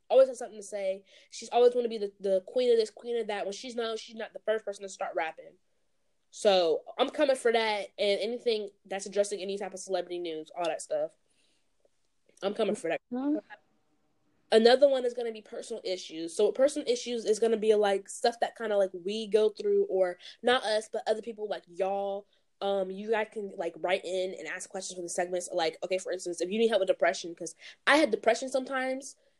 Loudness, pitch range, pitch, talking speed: -30 LUFS, 195-240 Hz, 215 Hz, 225 wpm